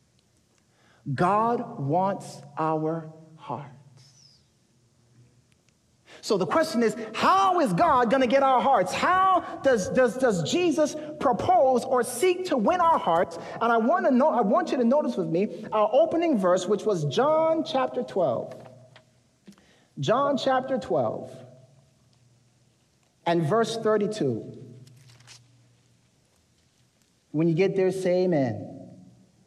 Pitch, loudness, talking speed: 190 Hz, -24 LUFS, 120 wpm